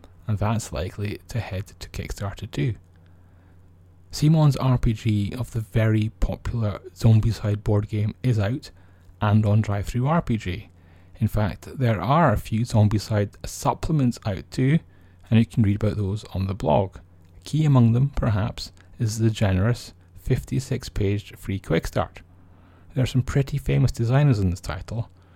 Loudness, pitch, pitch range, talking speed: -24 LUFS, 105 Hz, 90-120 Hz, 150 wpm